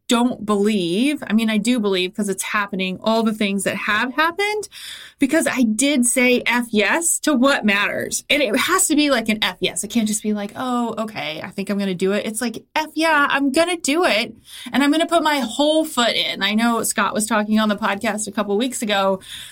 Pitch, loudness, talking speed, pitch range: 225 Hz, -19 LUFS, 235 wpm, 205-280 Hz